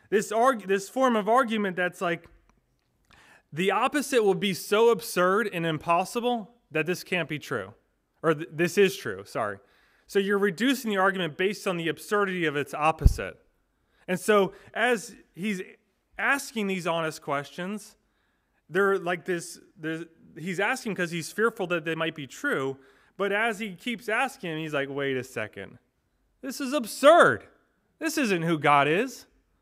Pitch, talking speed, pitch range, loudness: 190 Hz, 160 wpm, 165-225 Hz, -26 LUFS